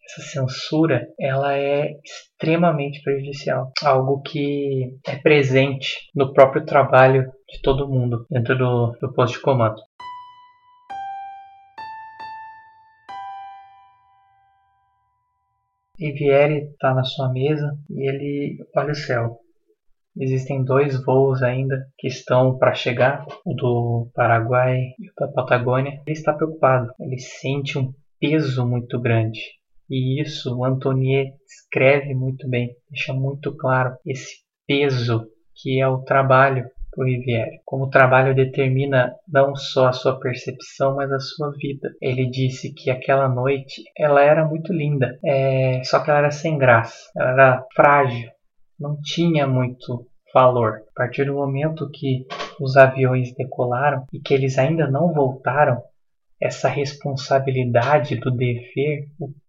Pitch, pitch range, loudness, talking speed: 135 Hz, 130-150 Hz, -20 LUFS, 130 wpm